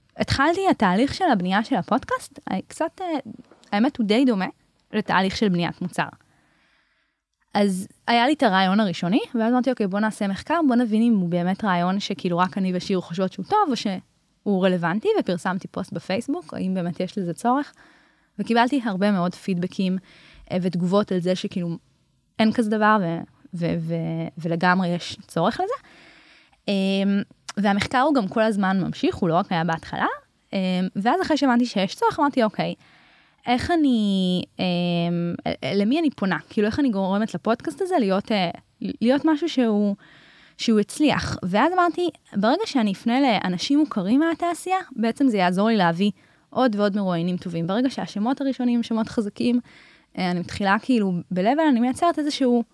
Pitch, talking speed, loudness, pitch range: 205 Hz, 155 wpm, -23 LUFS, 185-250 Hz